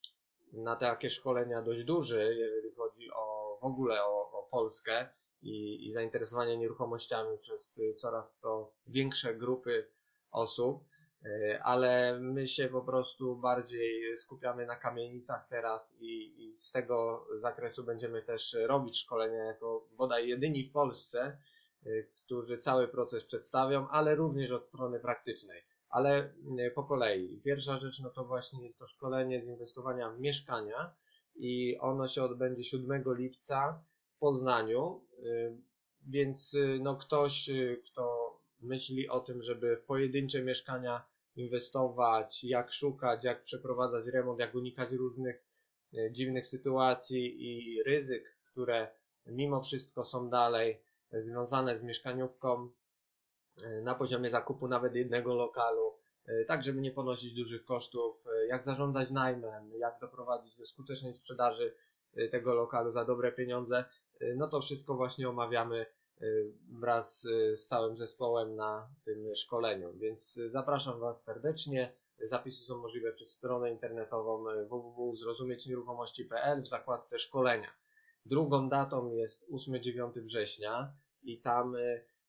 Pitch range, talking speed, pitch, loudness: 120-140 Hz, 125 wpm, 125 Hz, -36 LUFS